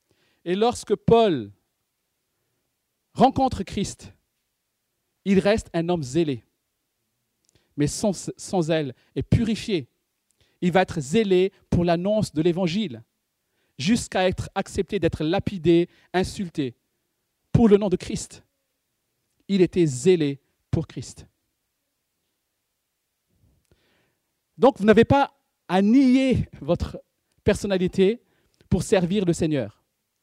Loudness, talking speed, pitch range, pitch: -23 LUFS, 105 wpm, 140-205 Hz, 175 Hz